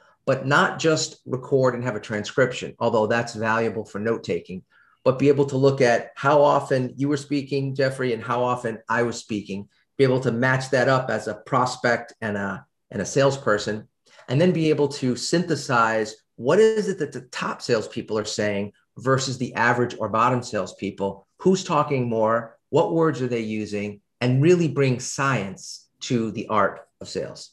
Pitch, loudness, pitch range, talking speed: 125 Hz, -23 LUFS, 110-140 Hz, 180 wpm